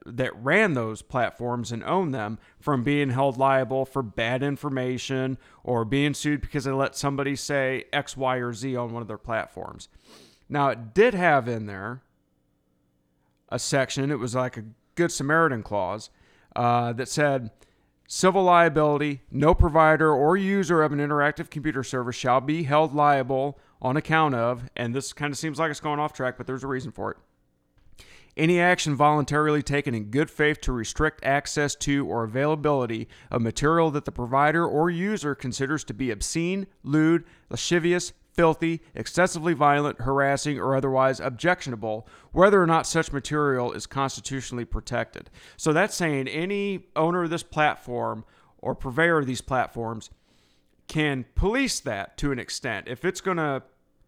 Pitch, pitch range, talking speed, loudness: 140 Hz, 125-155 Hz, 165 wpm, -25 LUFS